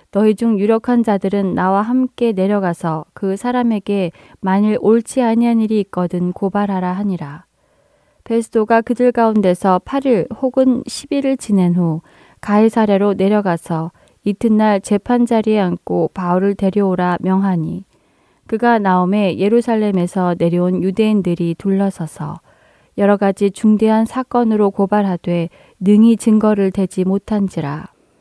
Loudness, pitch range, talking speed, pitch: -16 LUFS, 185-225 Hz, 290 characters per minute, 200 Hz